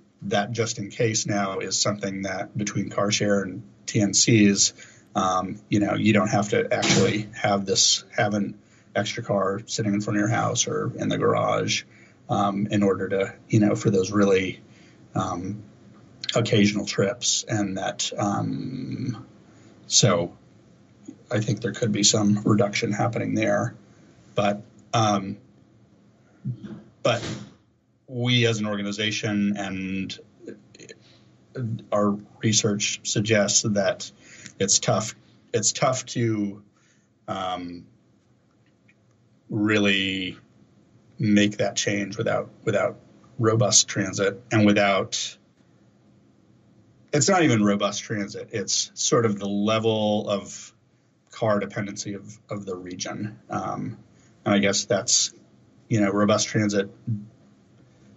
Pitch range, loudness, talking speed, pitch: 100-110 Hz, -23 LUFS, 120 wpm, 105 Hz